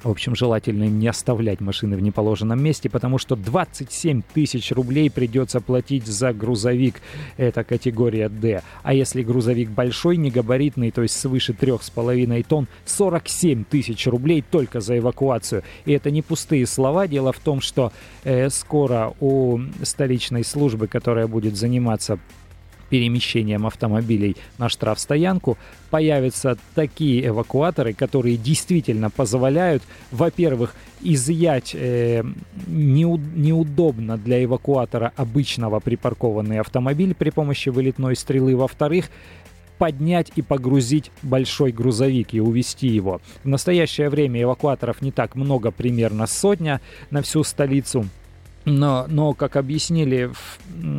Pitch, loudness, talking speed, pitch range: 125 Hz, -21 LUFS, 125 wpm, 115-145 Hz